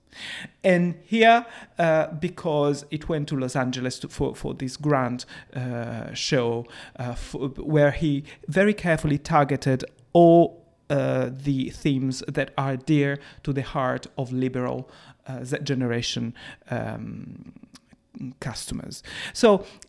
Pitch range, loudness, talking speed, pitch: 130-160 Hz, -24 LUFS, 120 wpm, 140 Hz